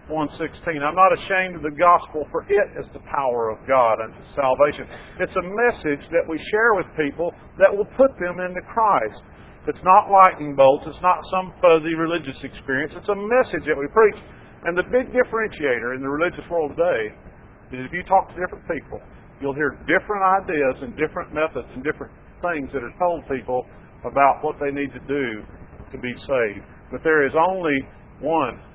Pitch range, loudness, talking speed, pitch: 135-185 Hz, -21 LUFS, 190 wpm, 155 Hz